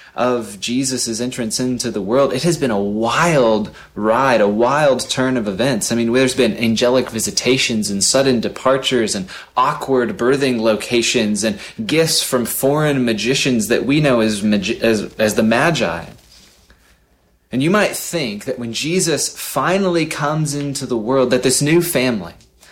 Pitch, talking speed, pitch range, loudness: 125 Hz, 155 wpm, 115-140 Hz, -17 LUFS